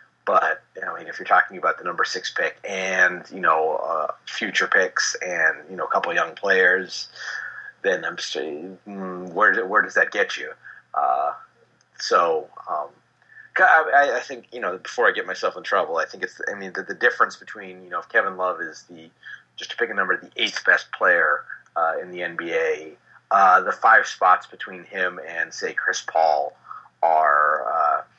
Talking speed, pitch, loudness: 195 wpm, 100 Hz, -21 LUFS